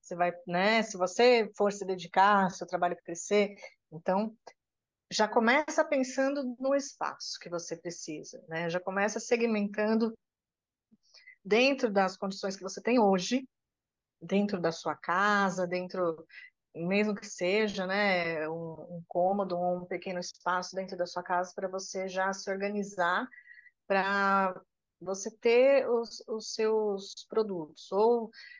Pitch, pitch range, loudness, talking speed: 195 Hz, 180-225 Hz, -30 LUFS, 130 wpm